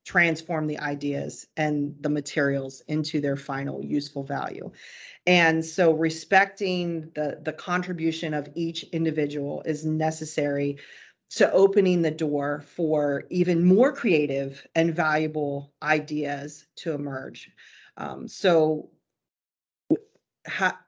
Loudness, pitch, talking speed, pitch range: -25 LUFS, 155 Hz, 110 wpm, 145-165 Hz